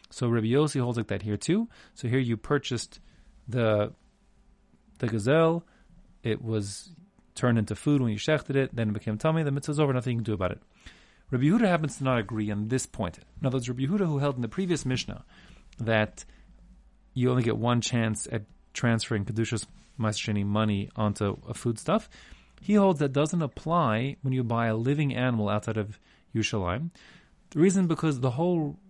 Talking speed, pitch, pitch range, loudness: 185 wpm, 120 Hz, 110-150 Hz, -28 LUFS